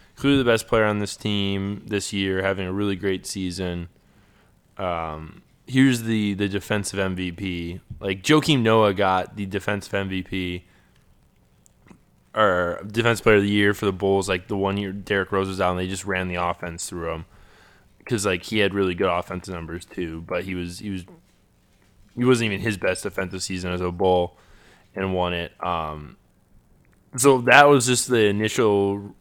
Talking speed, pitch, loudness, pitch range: 175 wpm, 95 Hz, -22 LUFS, 90-105 Hz